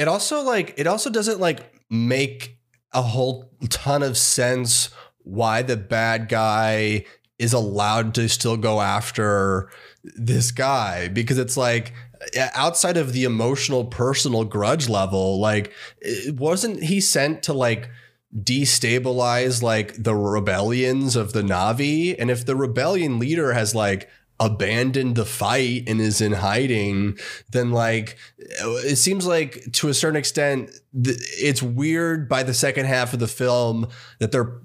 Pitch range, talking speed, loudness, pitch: 110-135 Hz, 145 wpm, -21 LUFS, 125 Hz